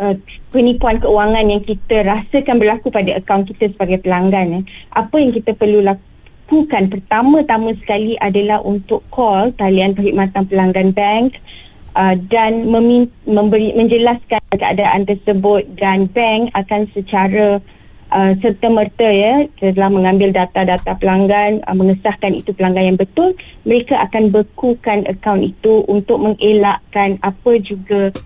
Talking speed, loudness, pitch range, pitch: 130 wpm, -14 LUFS, 195-225 Hz, 210 Hz